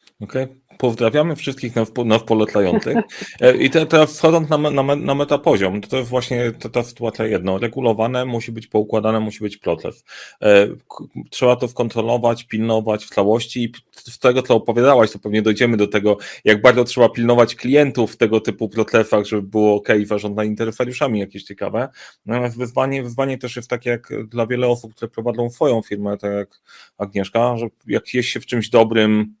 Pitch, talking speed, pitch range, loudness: 115 Hz, 170 wpm, 110-125 Hz, -18 LUFS